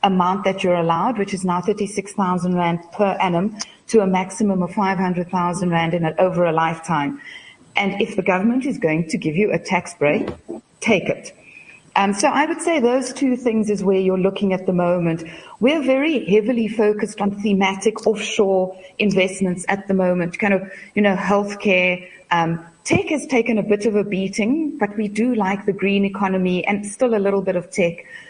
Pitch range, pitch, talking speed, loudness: 180-220 Hz, 195 Hz, 205 wpm, -20 LUFS